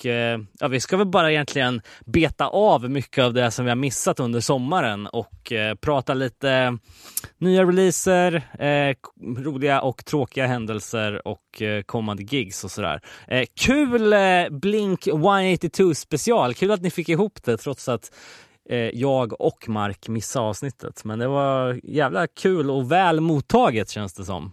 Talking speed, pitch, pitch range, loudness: 145 wpm, 135 Hz, 115-170 Hz, -22 LUFS